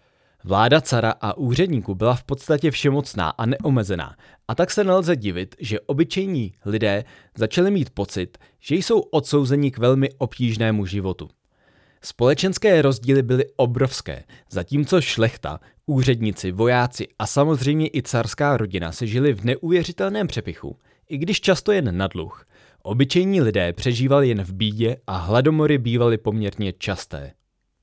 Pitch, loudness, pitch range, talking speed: 125 Hz, -21 LUFS, 105-145 Hz, 135 wpm